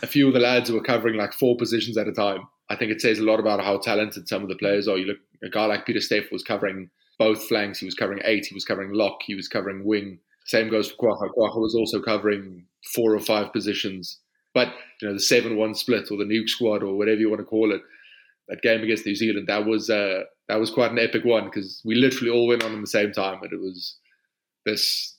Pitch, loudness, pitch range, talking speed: 110 Hz, -23 LUFS, 100-115 Hz, 255 wpm